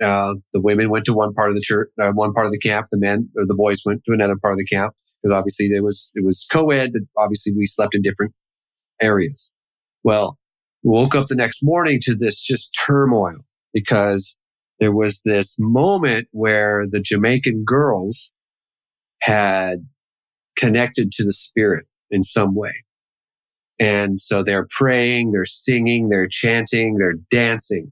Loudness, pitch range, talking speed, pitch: -18 LUFS, 100-115 Hz, 170 wpm, 105 Hz